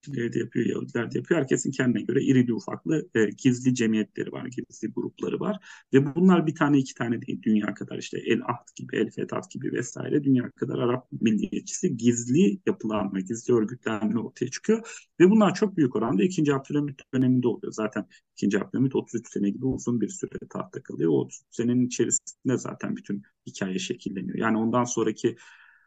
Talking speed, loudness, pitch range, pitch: 170 wpm, -26 LUFS, 110-145 Hz, 125 Hz